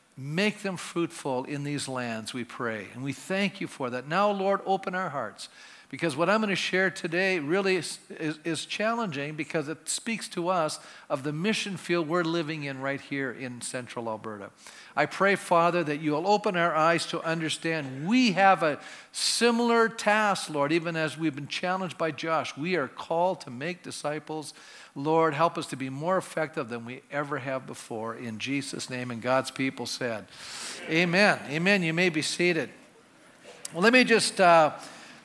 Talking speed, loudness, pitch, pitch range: 185 wpm, -27 LUFS, 160 Hz, 140-185 Hz